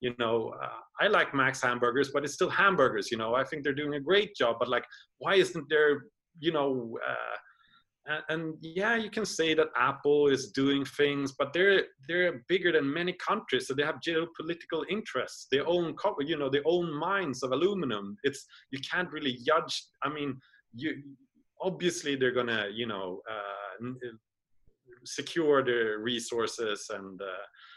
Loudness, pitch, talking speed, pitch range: -30 LUFS, 145 Hz, 170 wpm, 125-170 Hz